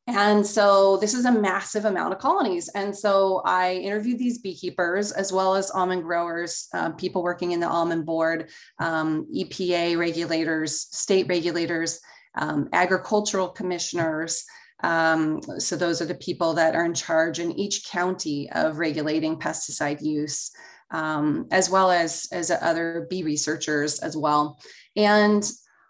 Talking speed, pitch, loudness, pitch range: 145 wpm, 170 Hz, -24 LUFS, 160-190 Hz